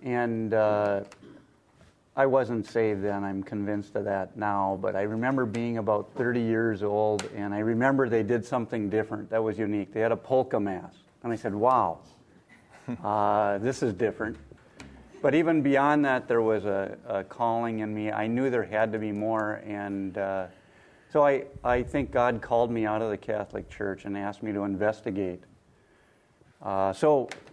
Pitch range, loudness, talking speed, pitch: 100-120 Hz, -28 LUFS, 175 wpm, 110 Hz